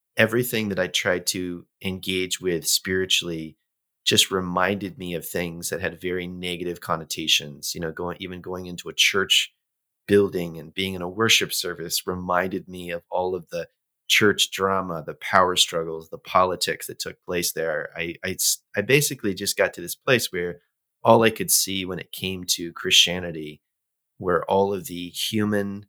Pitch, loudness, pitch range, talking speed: 90 Hz, -23 LUFS, 85-95 Hz, 170 wpm